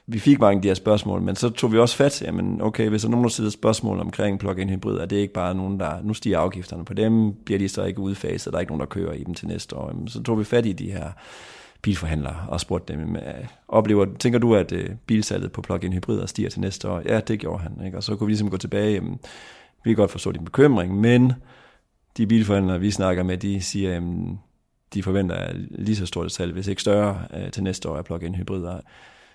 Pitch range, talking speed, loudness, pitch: 90-110 Hz, 245 wpm, -23 LUFS, 100 Hz